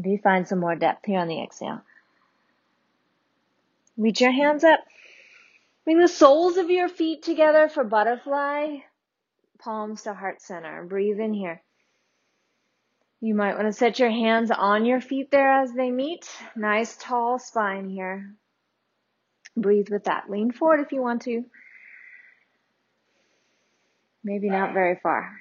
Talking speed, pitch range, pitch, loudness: 145 wpm, 205-285 Hz, 230 Hz, -23 LUFS